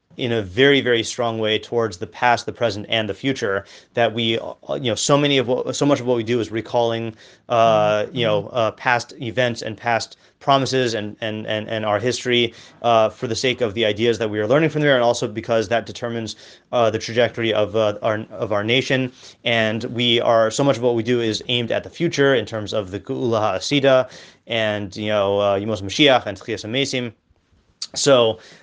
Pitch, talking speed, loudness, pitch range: 115 Hz, 210 wpm, -20 LUFS, 110-125 Hz